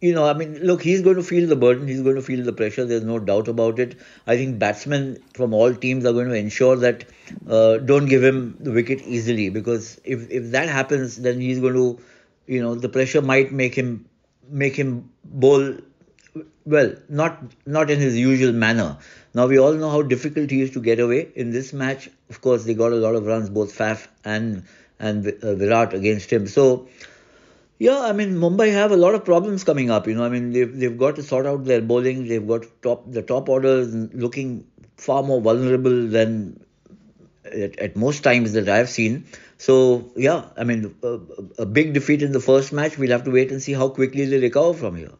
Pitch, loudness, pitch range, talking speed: 125 Hz, -20 LUFS, 115-135 Hz, 215 wpm